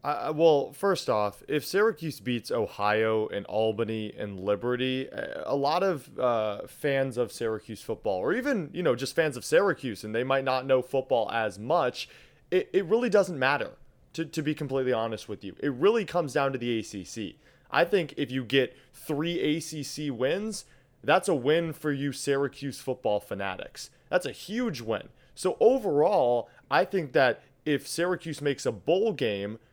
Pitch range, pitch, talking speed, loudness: 115-155 Hz, 135 Hz, 175 wpm, -28 LUFS